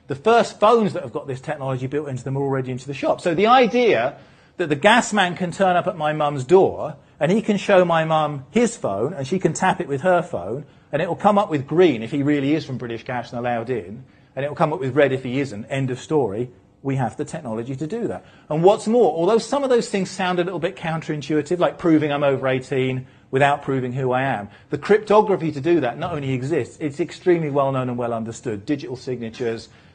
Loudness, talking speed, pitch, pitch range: -21 LUFS, 245 wpm, 150 Hz, 130-180 Hz